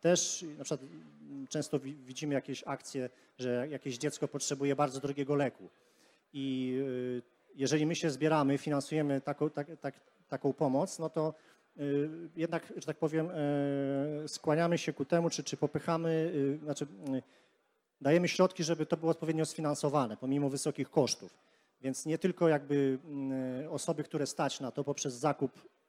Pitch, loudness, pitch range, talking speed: 145 Hz, -34 LUFS, 135-155 Hz, 140 wpm